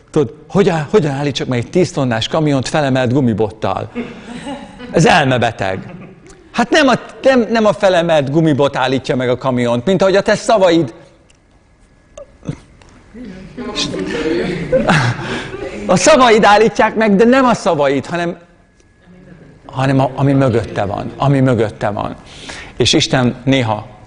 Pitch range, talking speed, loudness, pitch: 125-195 Hz, 125 wpm, -14 LUFS, 150 Hz